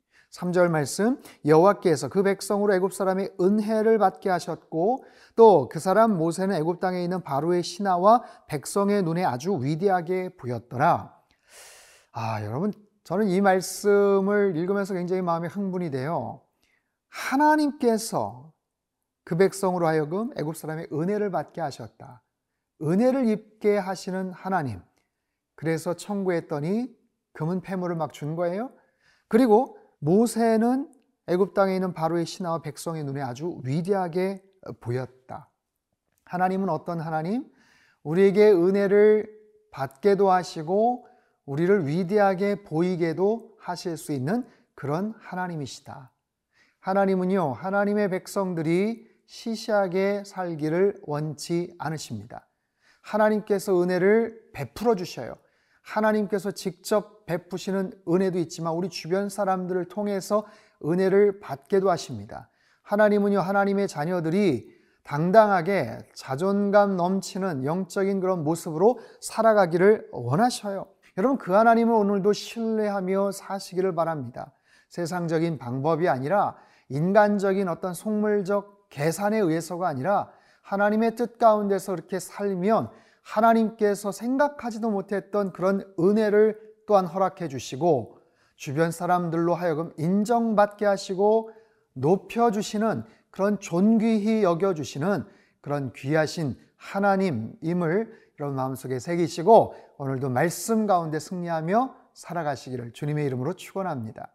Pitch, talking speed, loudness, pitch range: 190 Hz, 295 characters per minute, -25 LUFS, 165-210 Hz